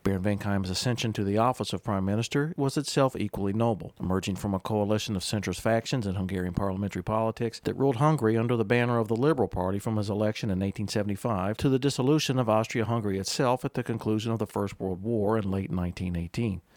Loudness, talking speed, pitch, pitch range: -28 LUFS, 200 wpm, 110 Hz, 100-120 Hz